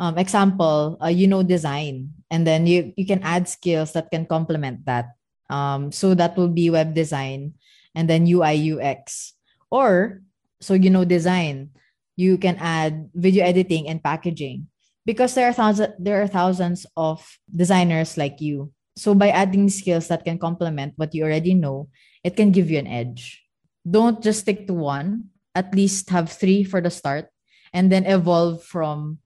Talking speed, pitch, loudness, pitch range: 170 wpm, 170 Hz, -20 LUFS, 155-190 Hz